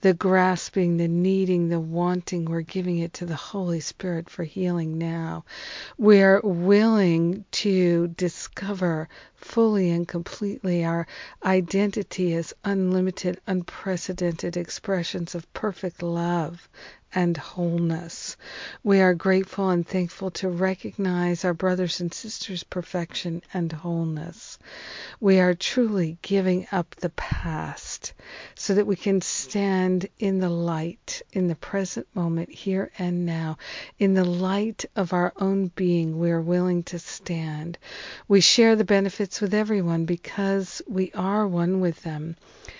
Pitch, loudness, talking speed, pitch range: 180 Hz, -25 LUFS, 130 wpm, 170-195 Hz